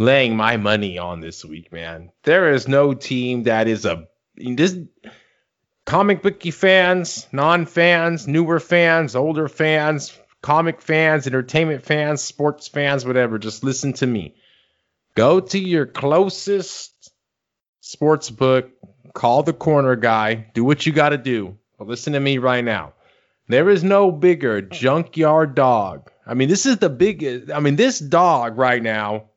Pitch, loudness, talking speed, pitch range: 145 Hz, -18 LUFS, 155 wpm, 120-165 Hz